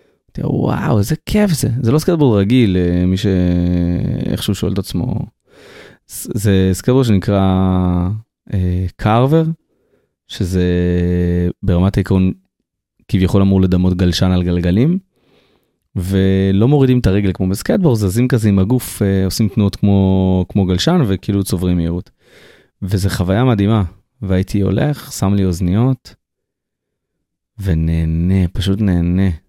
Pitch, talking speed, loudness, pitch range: 95 Hz, 115 wpm, -15 LUFS, 90-110 Hz